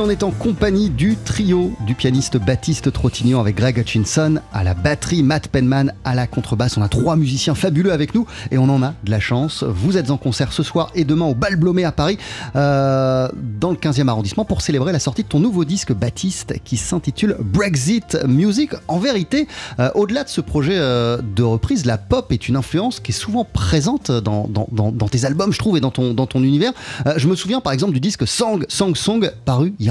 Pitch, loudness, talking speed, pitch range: 140 Hz, -18 LUFS, 225 wpm, 125-180 Hz